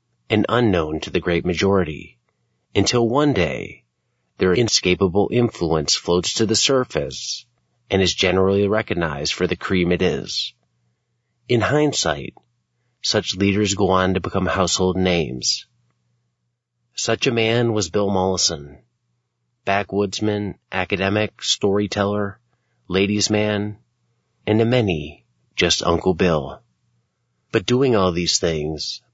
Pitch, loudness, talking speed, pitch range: 95 Hz, -20 LUFS, 115 wpm, 85-110 Hz